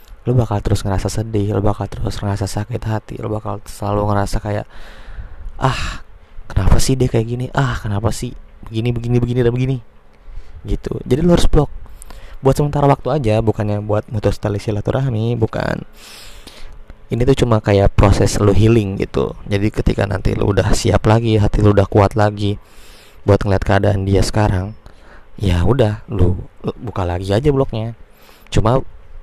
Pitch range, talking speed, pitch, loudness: 100-120 Hz, 160 wpm, 105 Hz, -17 LUFS